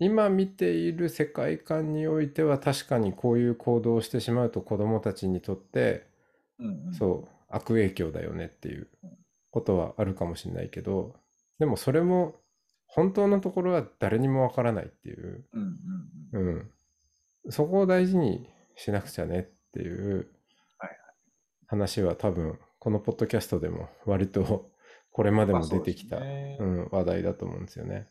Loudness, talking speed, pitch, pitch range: -29 LUFS, 305 characters per minute, 115 Hz, 95-155 Hz